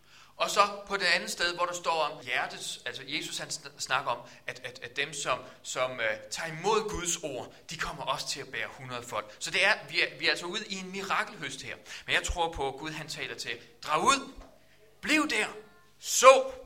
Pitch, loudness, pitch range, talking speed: 160 Hz, -29 LUFS, 135-195 Hz, 225 wpm